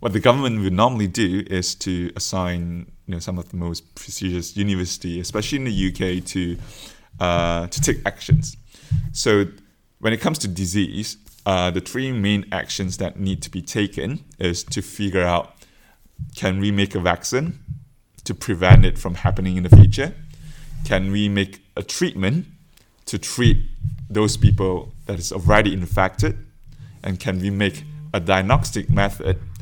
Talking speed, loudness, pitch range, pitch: 160 wpm, -21 LUFS, 95-115 Hz, 100 Hz